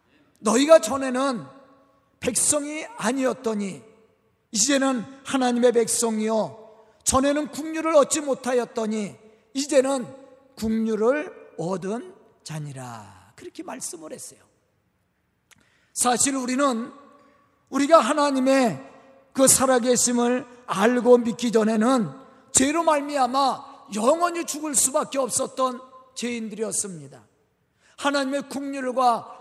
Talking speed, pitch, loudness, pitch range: 235 characters per minute, 255 Hz, -22 LUFS, 225-275 Hz